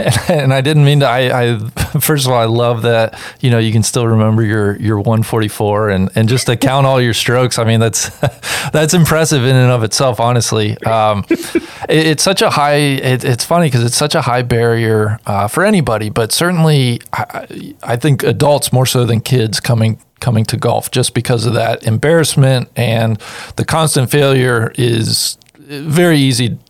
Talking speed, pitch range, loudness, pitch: 195 wpm, 115-145 Hz, -13 LUFS, 125 Hz